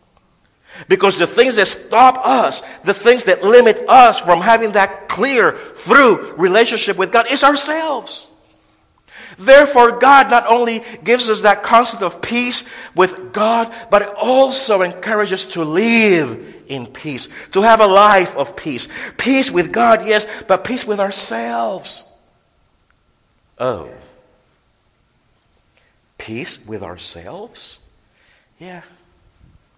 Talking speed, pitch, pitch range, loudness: 120 wpm, 210 Hz, 175-240 Hz, -13 LUFS